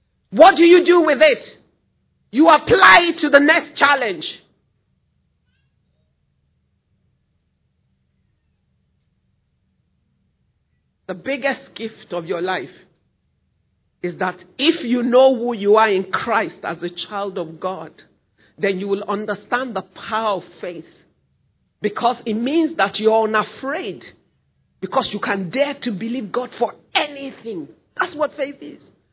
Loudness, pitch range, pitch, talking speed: -17 LUFS, 175-265 Hz, 210 Hz, 130 wpm